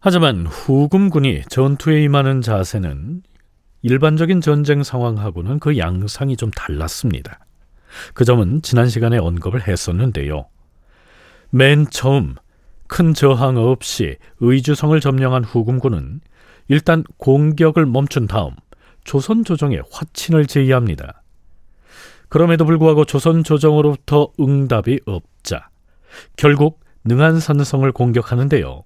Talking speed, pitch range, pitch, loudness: 265 characters per minute, 105-150 Hz, 135 Hz, -16 LUFS